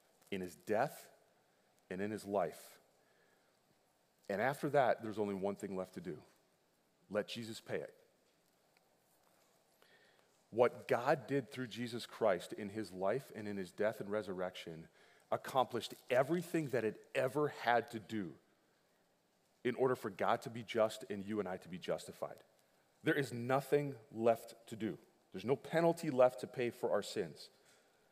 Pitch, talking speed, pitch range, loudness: 115 Hz, 155 wpm, 105-130 Hz, -39 LUFS